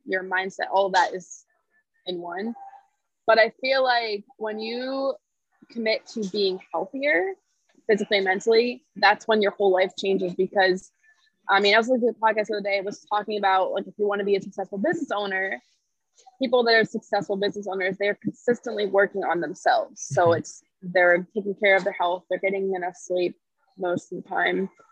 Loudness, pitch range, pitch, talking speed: -24 LUFS, 190-245 Hz, 205 Hz, 195 wpm